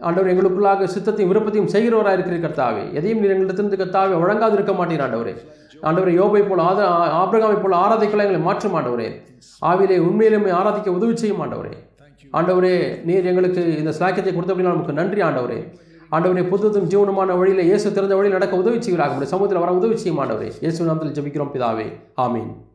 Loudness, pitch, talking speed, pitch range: -18 LUFS, 185 Hz, 145 wpm, 165-200 Hz